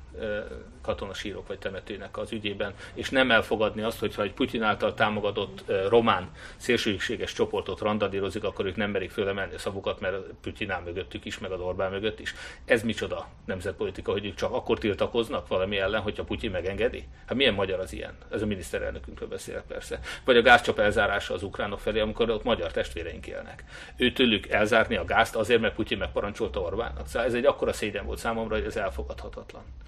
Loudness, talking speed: -28 LUFS, 175 wpm